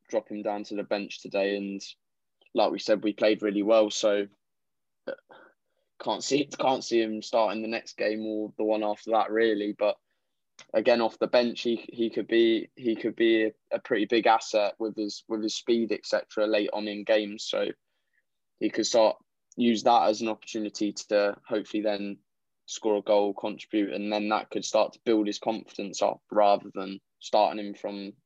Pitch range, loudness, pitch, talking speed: 105-115 Hz, -27 LUFS, 105 Hz, 190 wpm